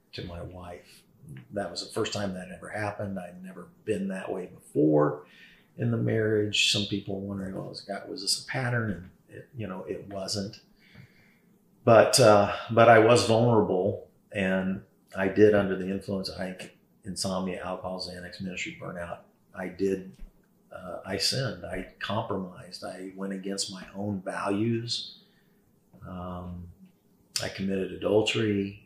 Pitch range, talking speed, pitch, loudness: 95-105 Hz, 150 wpm, 95 Hz, -27 LUFS